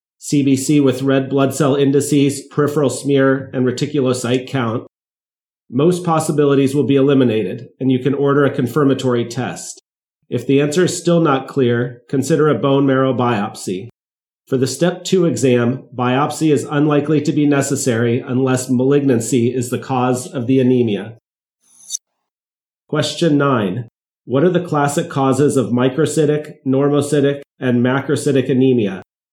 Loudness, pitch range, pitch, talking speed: -16 LUFS, 125-145 Hz, 135 Hz, 135 wpm